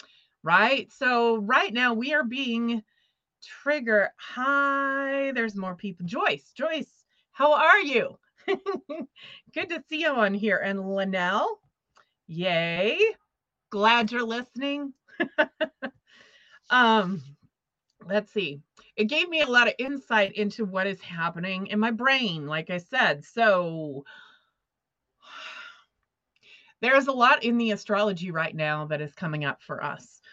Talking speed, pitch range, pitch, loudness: 125 wpm, 190-275 Hz, 225 Hz, -25 LUFS